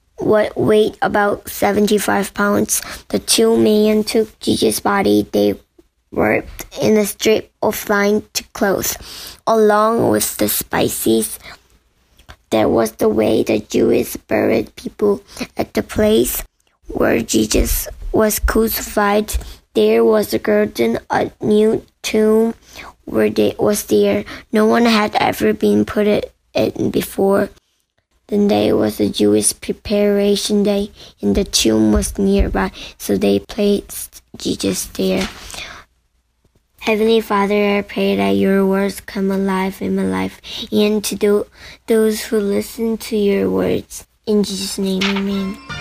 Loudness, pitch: -16 LUFS, 200 Hz